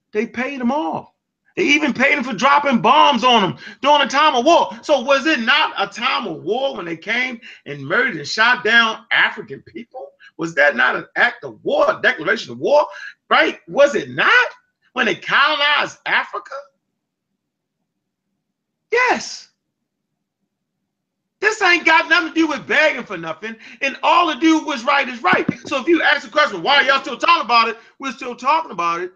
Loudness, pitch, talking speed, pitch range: -16 LUFS, 280 Hz, 190 wpm, 245-310 Hz